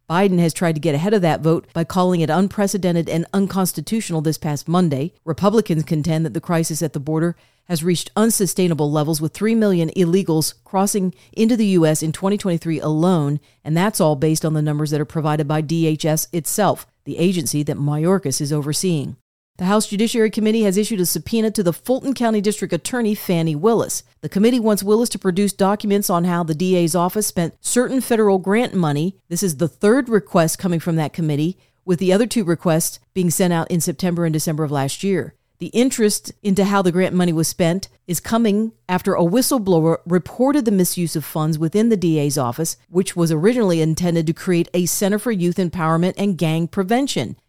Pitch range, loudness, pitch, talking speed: 160-200 Hz, -19 LUFS, 175 Hz, 195 wpm